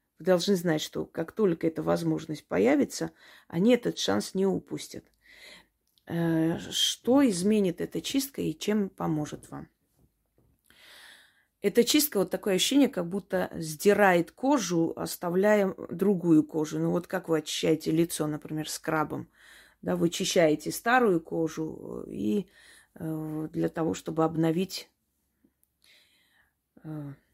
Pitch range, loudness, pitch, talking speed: 160-200 Hz, -27 LUFS, 170 Hz, 115 wpm